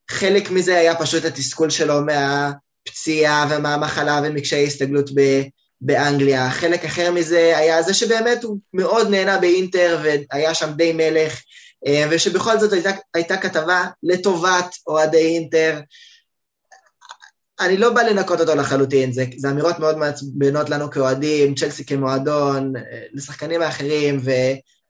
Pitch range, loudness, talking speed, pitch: 145-175 Hz, -18 LUFS, 125 wpm, 155 Hz